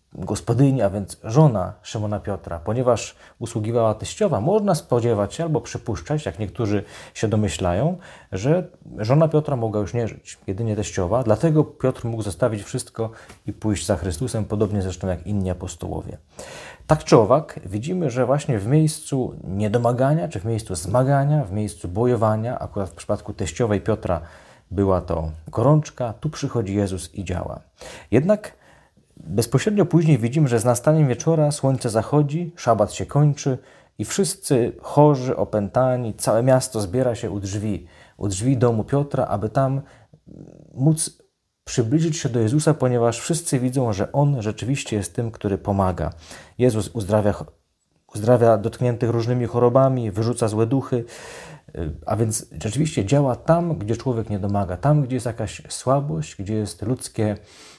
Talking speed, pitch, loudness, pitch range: 145 wpm, 120 Hz, -22 LUFS, 105-140 Hz